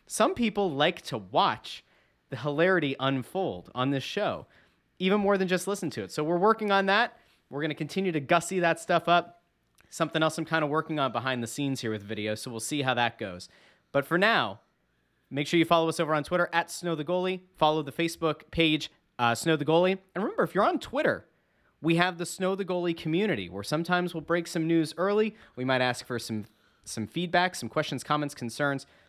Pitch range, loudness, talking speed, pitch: 135-175 Hz, -28 LUFS, 220 wpm, 160 Hz